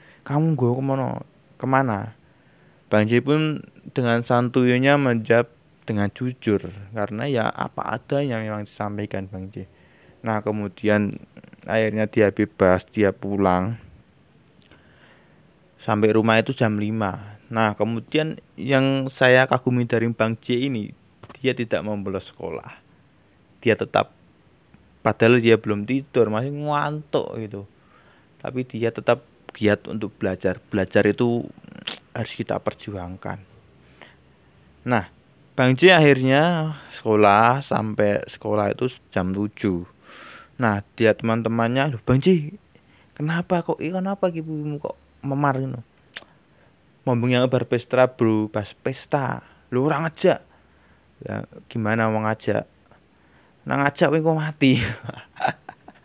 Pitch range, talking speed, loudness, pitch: 105-135 Hz, 115 wpm, -22 LUFS, 115 Hz